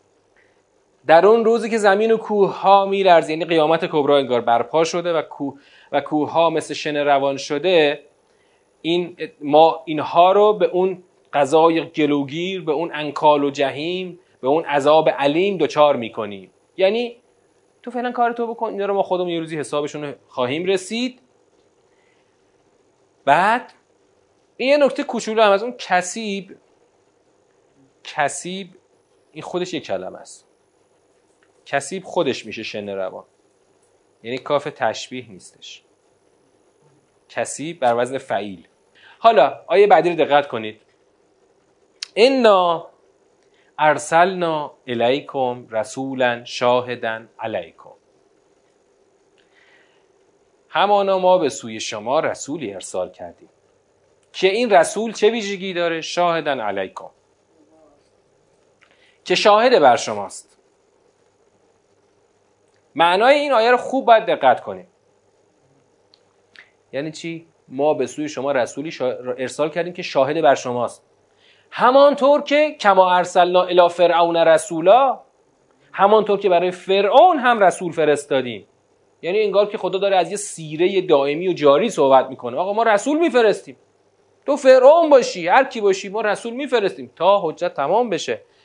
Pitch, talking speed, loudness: 190 Hz, 125 wpm, -18 LUFS